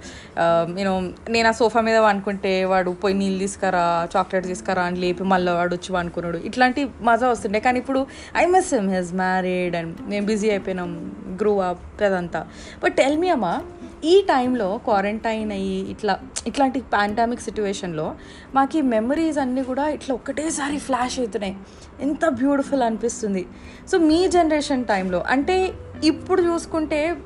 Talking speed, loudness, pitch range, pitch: 145 wpm, -22 LUFS, 190-275 Hz, 220 Hz